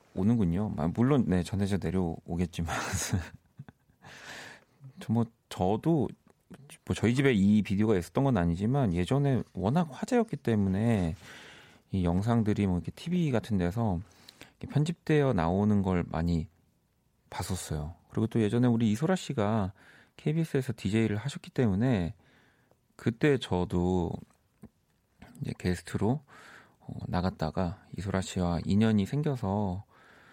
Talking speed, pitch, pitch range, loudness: 270 characters per minute, 105 Hz, 90-125 Hz, -30 LUFS